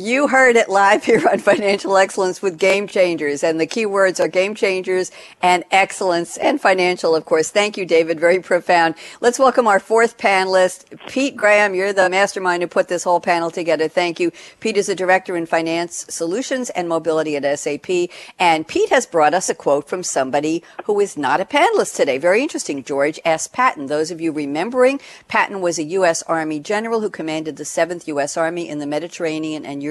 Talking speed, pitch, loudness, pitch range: 200 wpm, 180 Hz, -18 LUFS, 165-205 Hz